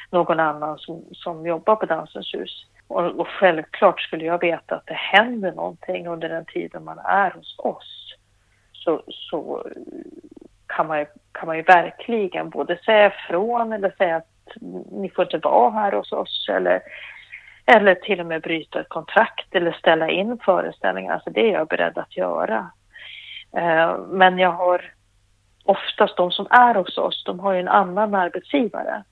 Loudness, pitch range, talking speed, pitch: -20 LUFS, 165-200 Hz, 170 wpm, 180 Hz